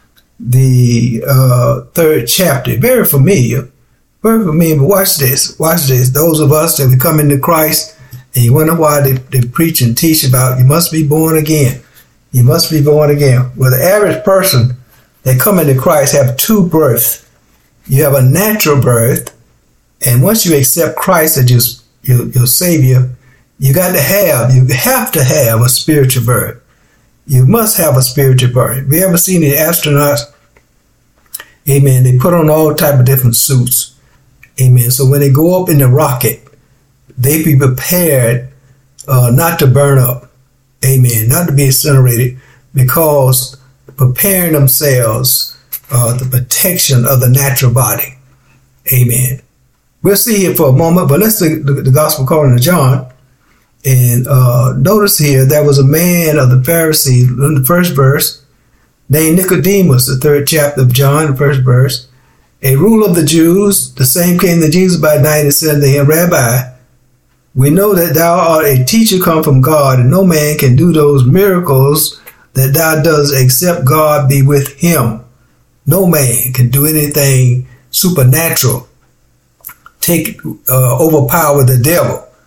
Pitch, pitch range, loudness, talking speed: 140 Hz, 130-155 Hz, -9 LUFS, 165 wpm